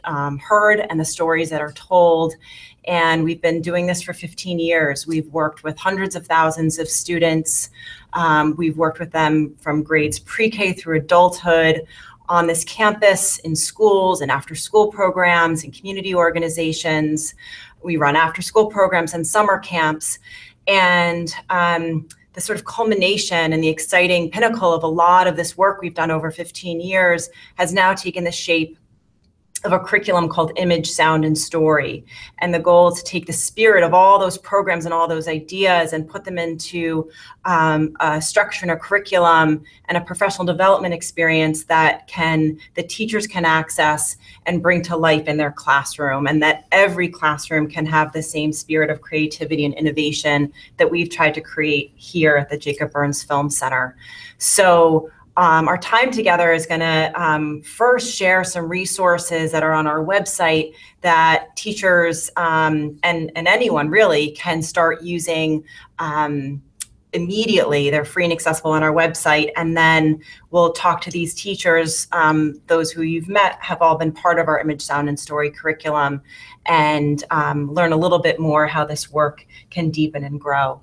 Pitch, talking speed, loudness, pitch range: 165 Hz, 170 wpm, -17 LUFS, 155-175 Hz